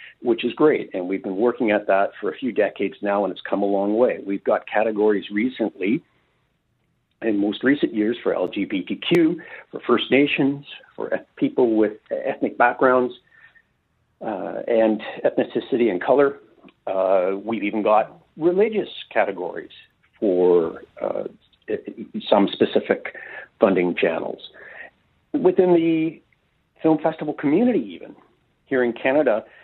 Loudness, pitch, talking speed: -21 LUFS, 140 Hz, 130 wpm